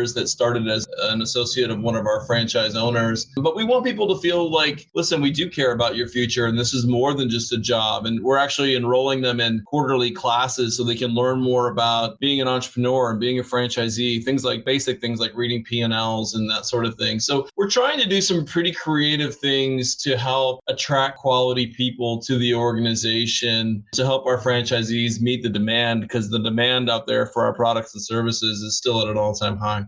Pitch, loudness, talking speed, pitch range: 120 Hz, -21 LUFS, 215 wpm, 115-130 Hz